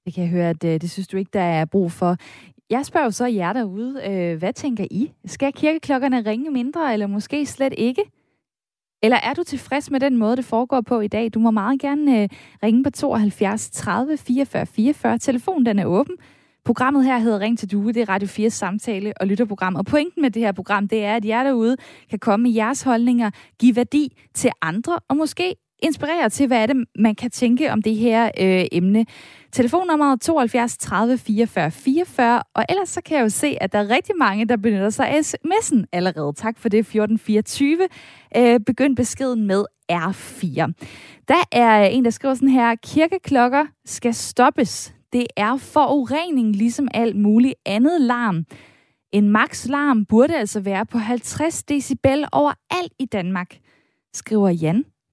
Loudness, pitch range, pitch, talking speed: -20 LUFS, 210-275 Hz, 235 Hz, 185 wpm